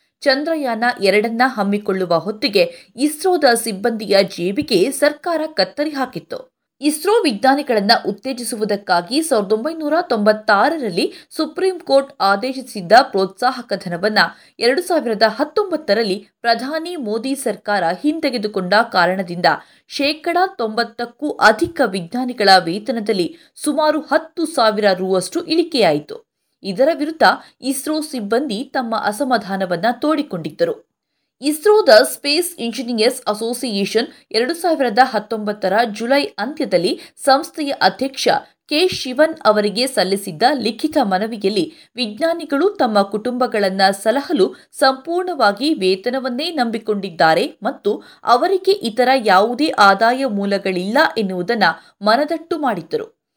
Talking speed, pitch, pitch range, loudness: 90 wpm, 250 Hz, 210-305 Hz, -17 LUFS